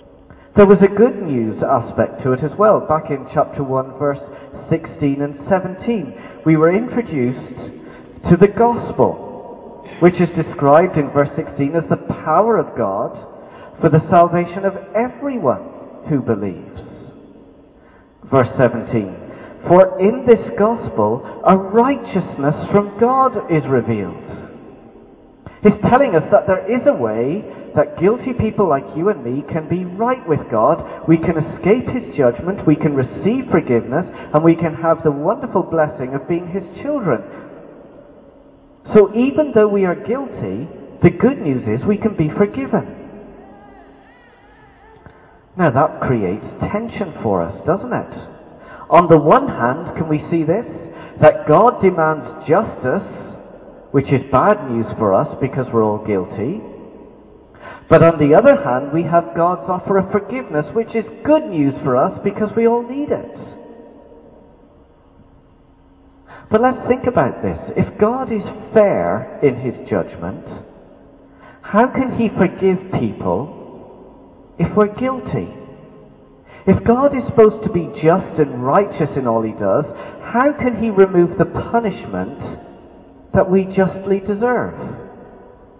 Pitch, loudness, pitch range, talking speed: 175 Hz, -16 LUFS, 145-215 Hz, 140 wpm